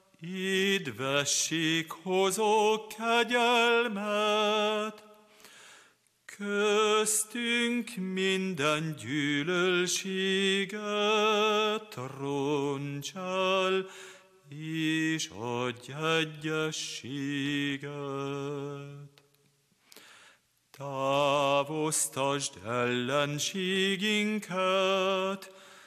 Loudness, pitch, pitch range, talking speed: -29 LUFS, 180 Hz, 145-210 Hz, 30 wpm